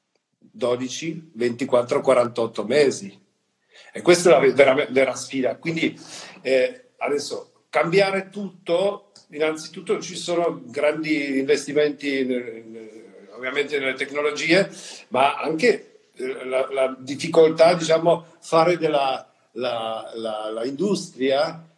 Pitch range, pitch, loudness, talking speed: 130-175 Hz, 155 Hz, -22 LUFS, 105 wpm